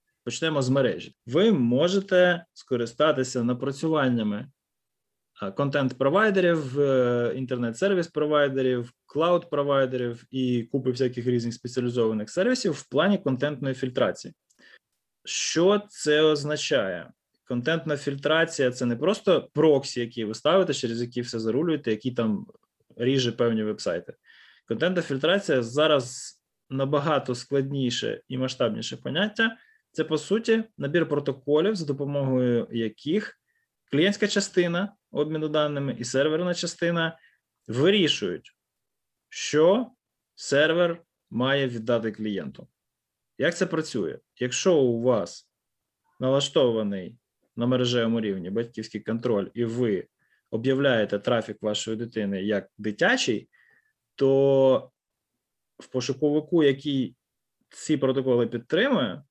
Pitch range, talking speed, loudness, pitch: 120-160 Hz, 100 wpm, -25 LUFS, 135 Hz